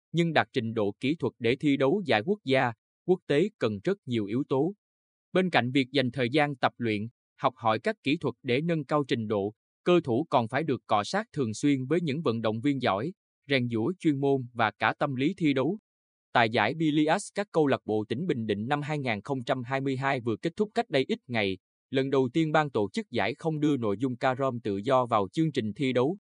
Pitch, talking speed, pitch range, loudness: 135 Hz, 230 wpm, 115-160 Hz, -28 LUFS